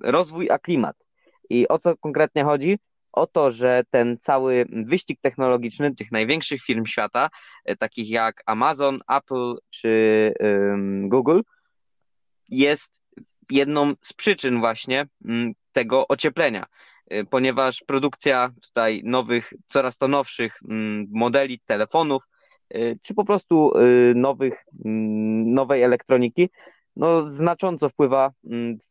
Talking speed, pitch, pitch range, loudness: 120 wpm, 130 Hz, 115-145 Hz, -22 LUFS